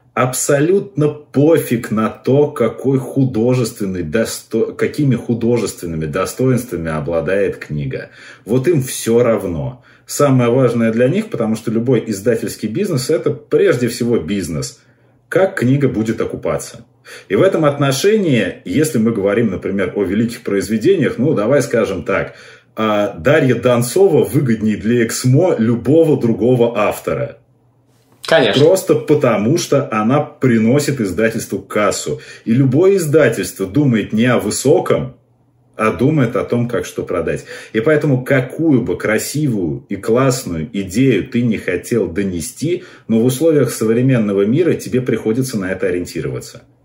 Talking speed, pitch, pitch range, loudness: 125 wpm, 120 Hz, 110-135 Hz, -16 LUFS